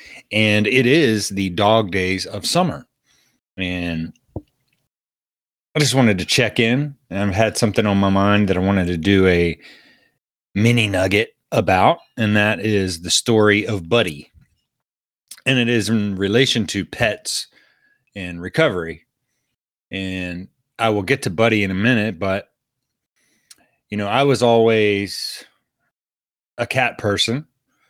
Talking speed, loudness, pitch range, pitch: 140 wpm, -18 LUFS, 95-115 Hz, 105 Hz